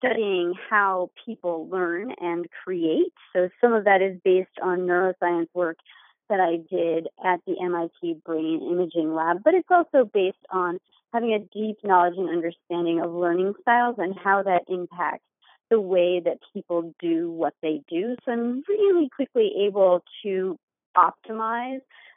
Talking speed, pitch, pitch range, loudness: 155 wpm, 185 Hz, 170-220 Hz, -24 LUFS